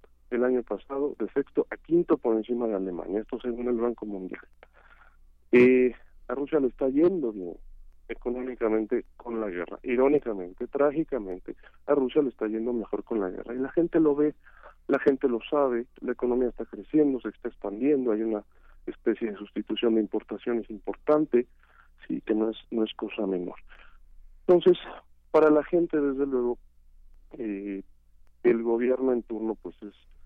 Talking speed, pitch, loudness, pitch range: 165 wpm, 120 Hz, -27 LUFS, 105-135 Hz